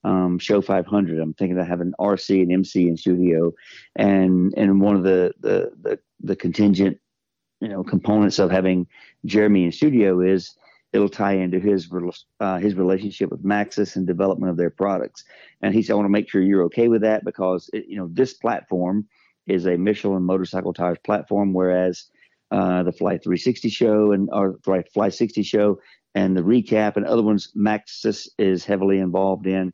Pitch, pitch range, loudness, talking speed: 95 Hz, 90-105 Hz, -21 LUFS, 185 wpm